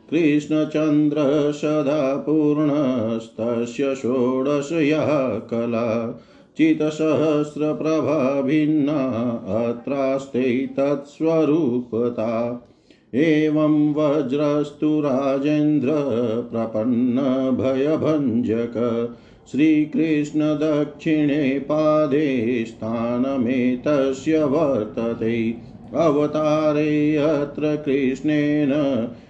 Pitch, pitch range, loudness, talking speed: 145 Hz, 125-150 Hz, -21 LUFS, 40 wpm